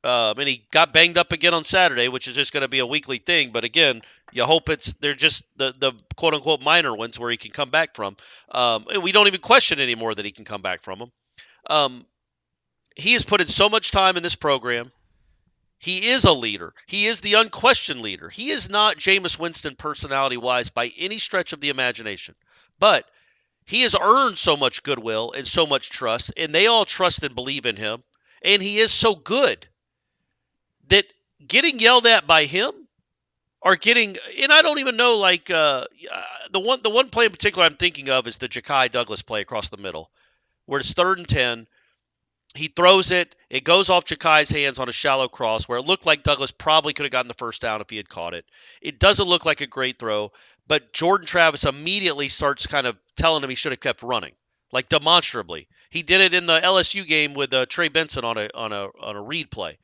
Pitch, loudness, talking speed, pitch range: 150 Hz, -19 LUFS, 220 wpm, 125-185 Hz